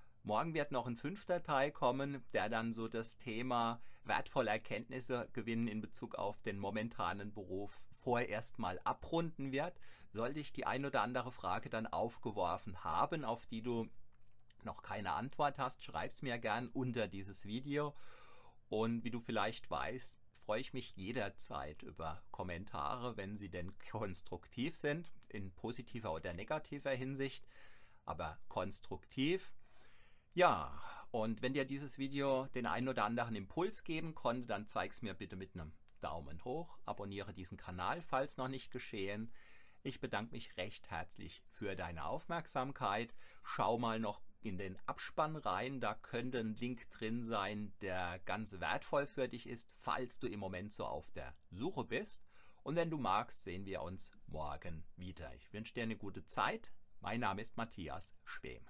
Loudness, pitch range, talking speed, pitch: -42 LUFS, 100-130 Hz, 160 wpm, 115 Hz